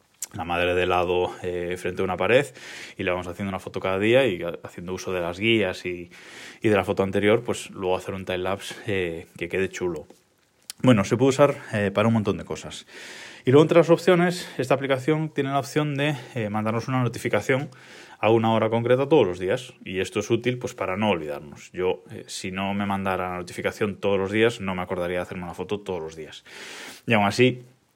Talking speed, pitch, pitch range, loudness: 220 wpm, 100 Hz, 90-125 Hz, -24 LUFS